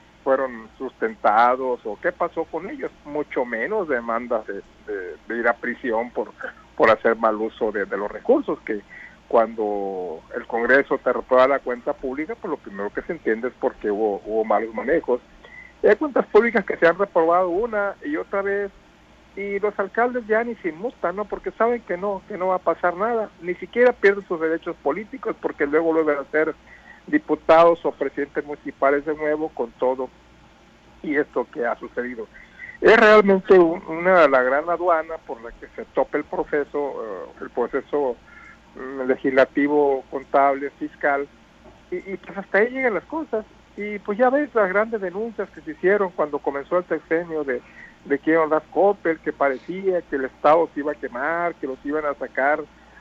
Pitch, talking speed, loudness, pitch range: 170 Hz, 185 wpm, -22 LUFS, 140-205 Hz